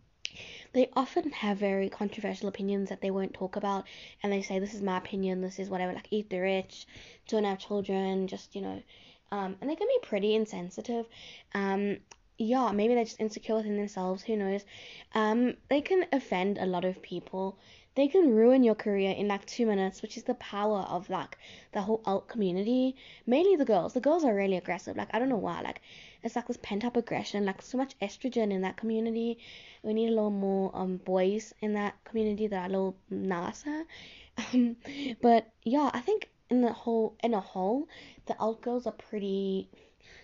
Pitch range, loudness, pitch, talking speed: 195-235 Hz, -31 LUFS, 210 Hz, 200 wpm